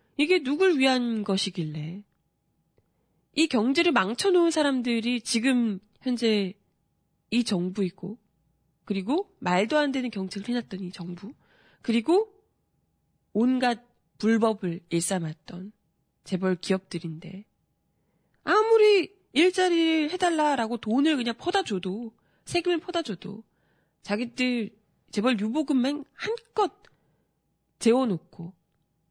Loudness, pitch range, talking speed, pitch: -26 LUFS, 190-300 Hz, 225 characters per minute, 230 Hz